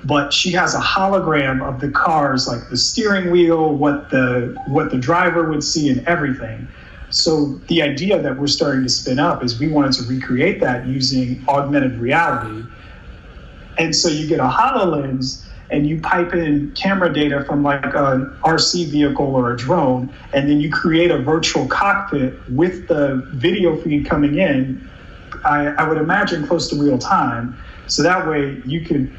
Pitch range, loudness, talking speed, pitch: 130-160 Hz, -17 LUFS, 175 wpm, 145 Hz